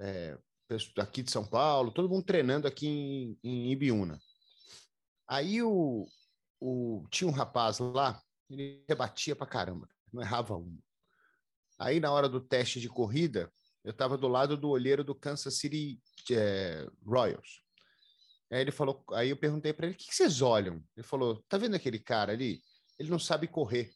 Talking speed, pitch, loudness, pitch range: 170 wpm, 135 Hz, -33 LUFS, 115-150 Hz